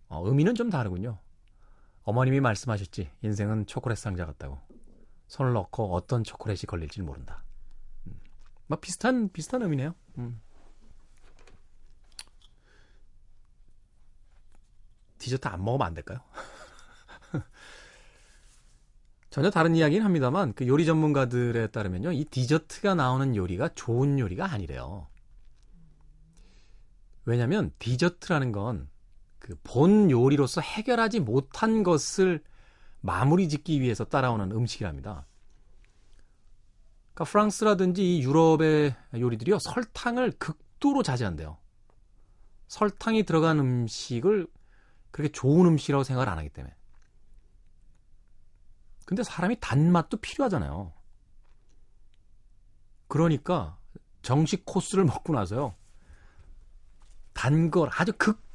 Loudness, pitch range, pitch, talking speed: -27 LUFS, 95-160 Hz, 120 Hz, 250 characters per minute